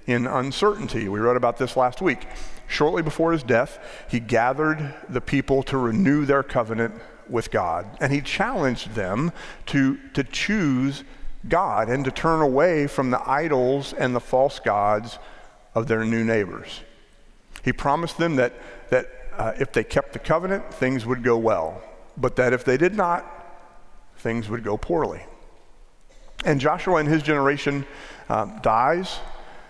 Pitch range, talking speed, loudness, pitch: 120-150 Hz, 155 wpm, -23 LUFS, 130 Hz